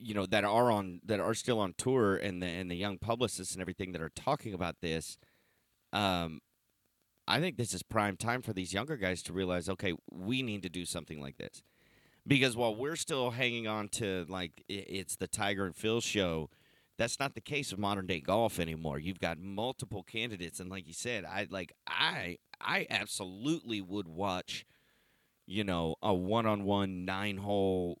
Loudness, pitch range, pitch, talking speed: -35 LUFS, 90-110 Hz, 100 Hz, 195 wpm